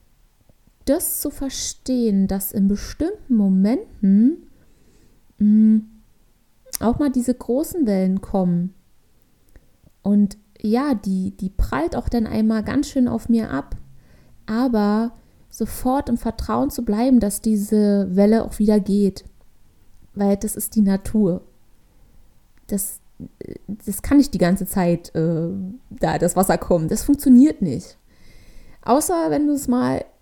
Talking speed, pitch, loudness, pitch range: 125 wpm, 215 Hz, -20 LUFS, 195-250 Hz